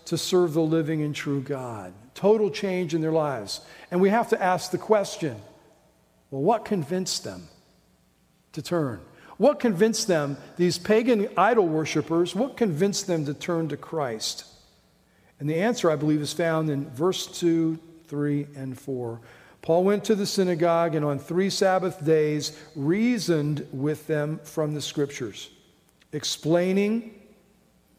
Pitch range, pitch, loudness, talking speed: 150-190 Hz, 165 Hz, -25 LUFS, 150 wpm